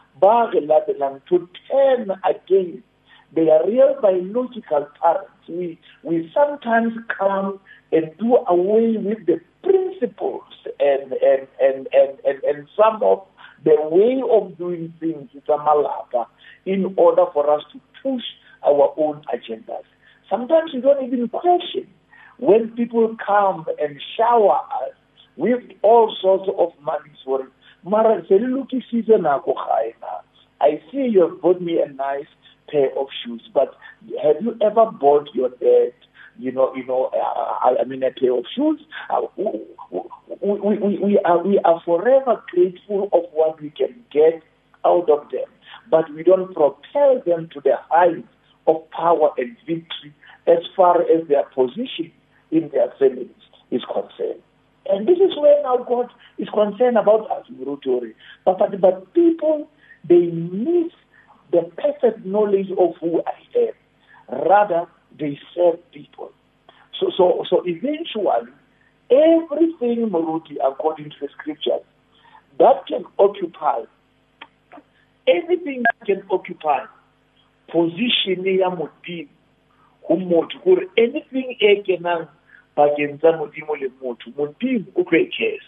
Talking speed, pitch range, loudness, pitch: 130 wpm, 155-250 Hz, -19 LUFS, 190 Hz